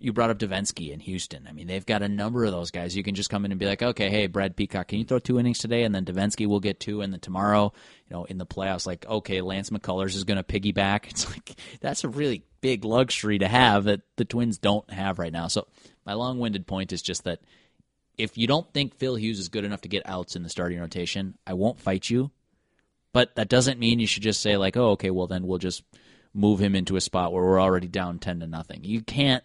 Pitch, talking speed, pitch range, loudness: 100 Hz, 260 wpm, 95-115 Hz, -26 LUFS